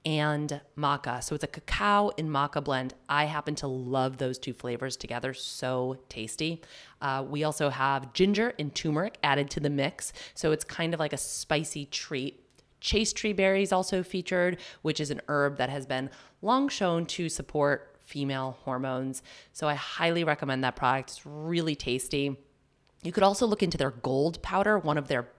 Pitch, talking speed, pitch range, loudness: 145 Hz, 180 wpm, 135-165 Hz, -29 LUFS